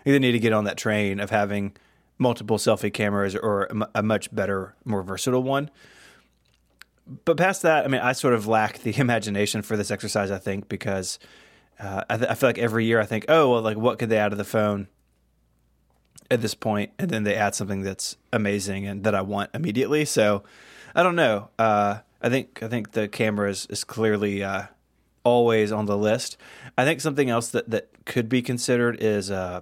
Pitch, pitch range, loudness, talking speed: 105 Hz, 100-120 Hz, -24 LUFS, 215 wpm